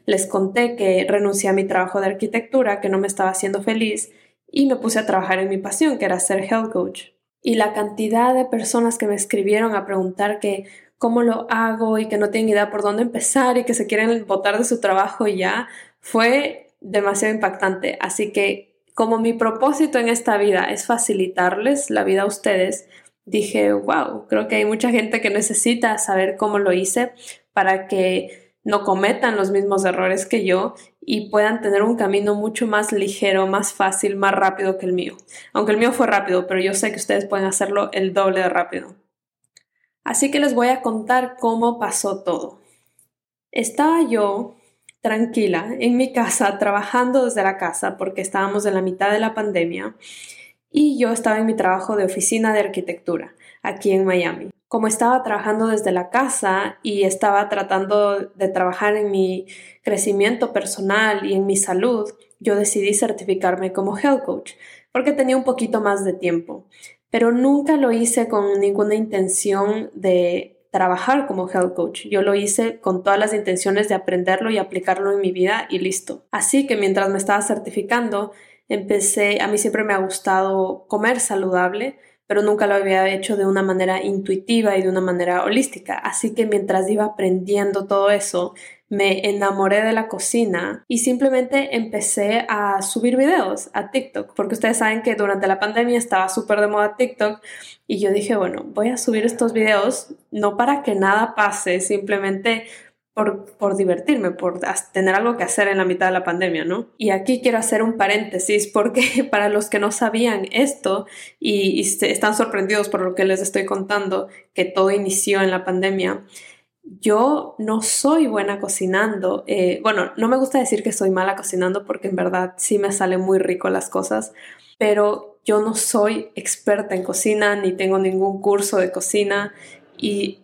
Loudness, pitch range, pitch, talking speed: -19 LUFS, 190-225 Hz, 205 Hz, 180 wpm